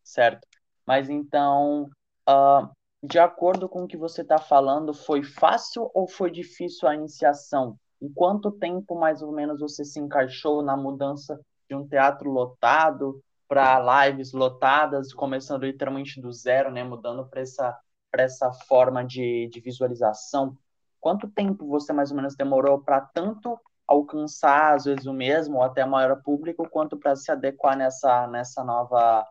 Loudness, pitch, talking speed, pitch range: -24 LUFS, 140 Hz, 160 wpm, 130-155 Hz